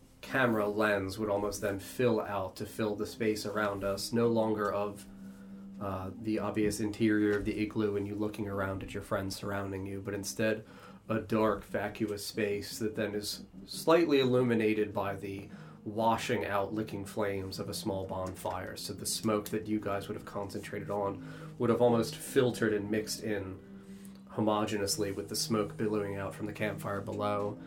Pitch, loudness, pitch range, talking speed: 105 Hz, -33 LUFS, 100-110 Hz, 175 wpm